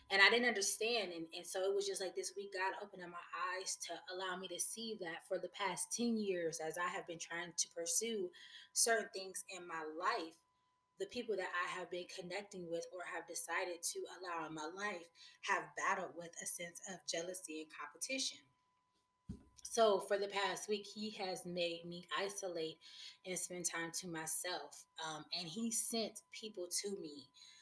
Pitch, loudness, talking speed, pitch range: 185 Hz, -40 LUFS, 190 wpm, 170-205 Hz